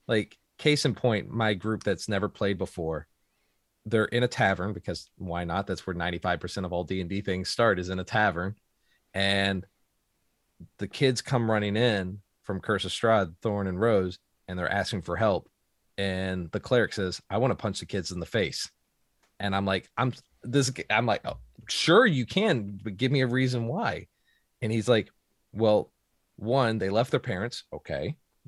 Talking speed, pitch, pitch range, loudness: 190 wpm, 100 Hz, 95-110 Hz, -28 LUFS